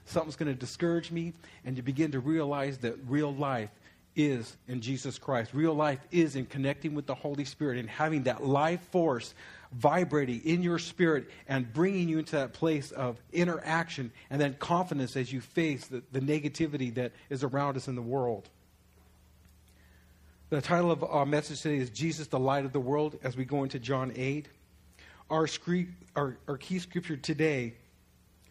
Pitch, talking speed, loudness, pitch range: 140 Hz, 180 wpm, -32 LUFS, 130-160 Hz